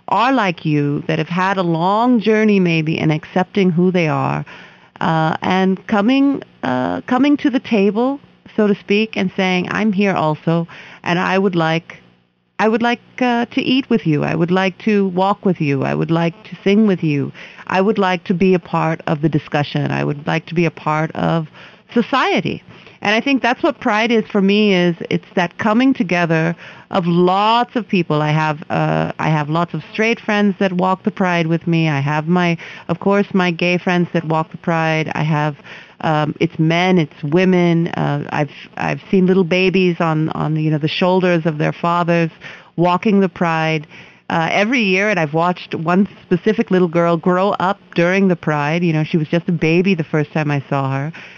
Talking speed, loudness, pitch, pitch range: 200 wpm, -17 LUFS, 180 Hz, 160-200 Hz